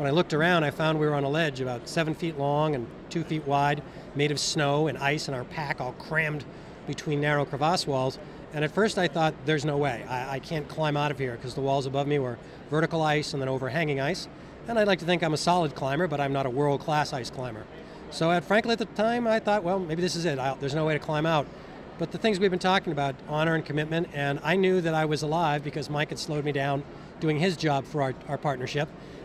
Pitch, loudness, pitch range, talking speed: 150 Hz, -27 LUFS, 140-165 Hz, 260 wpm